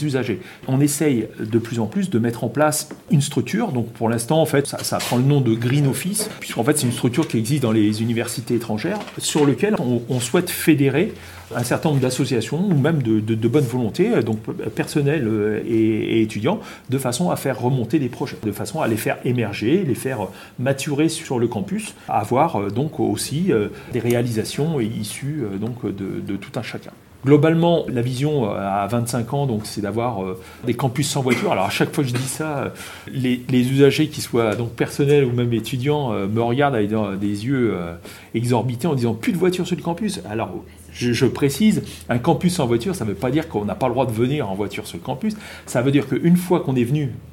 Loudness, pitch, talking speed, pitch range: -21 LUFS, 125 Hz, 220 wpm, 115-150 Hz